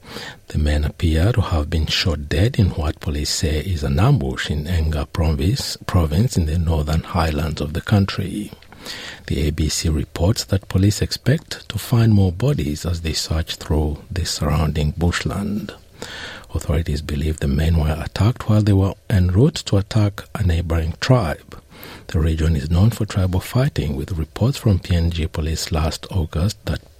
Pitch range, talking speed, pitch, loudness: 80-105 Hz, 160 wpm, 85 Hz, -20 LUFS